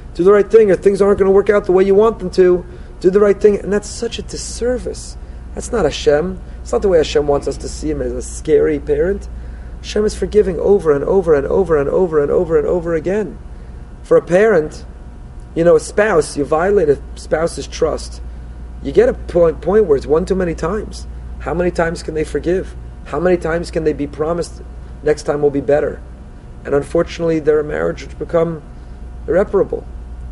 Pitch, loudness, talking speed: 170 Hz, -15 LUFS, 210 wpm